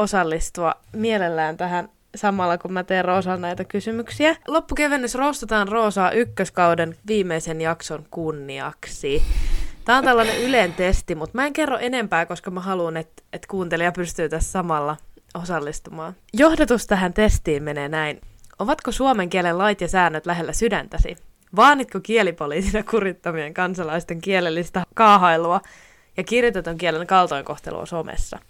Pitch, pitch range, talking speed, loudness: 185 Hz, 165-225 Hz, 130 wpm, -21 LUFS